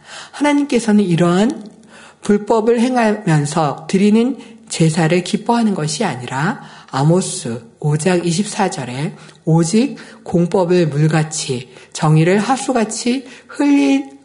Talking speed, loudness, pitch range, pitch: 225 characters per minute, -16 LUFS, 160-235 Hz, 195 Hz